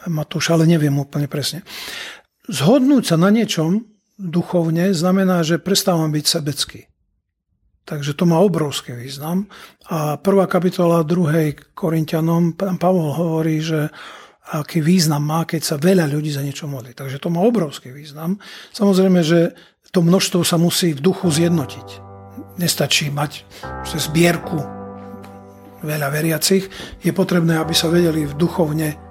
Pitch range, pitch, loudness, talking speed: 150-180 Hz, 165 Hz, -18 LUFS, 135 wpm